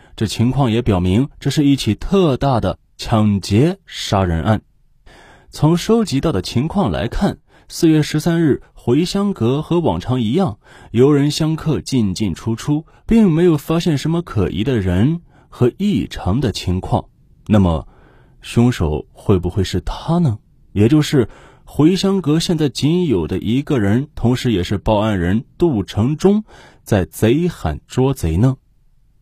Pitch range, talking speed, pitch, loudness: 105-155 Hz, 215 characters per minute, 130 Hz, -17 LUFS